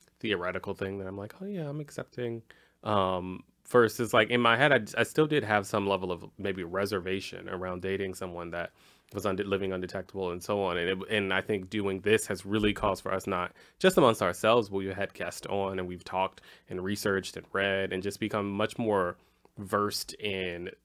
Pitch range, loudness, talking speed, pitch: 95-110 Hz, -30 LUFS, 205 wpm, 100 Hz